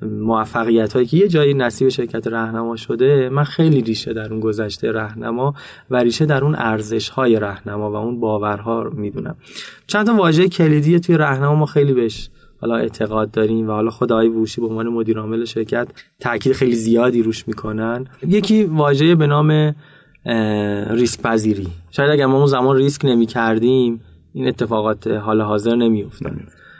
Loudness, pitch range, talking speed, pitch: -17 LUFS, 110-140 Hz, 165 wpm, 115 Hz